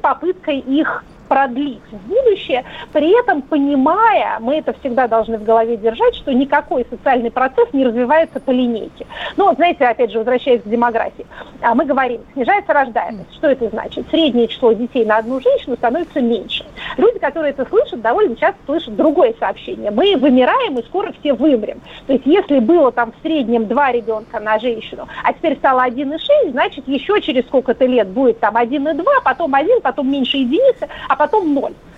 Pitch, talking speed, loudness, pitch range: 275 Hz, 170 wpm, -16 LUFS, 240-310 Hz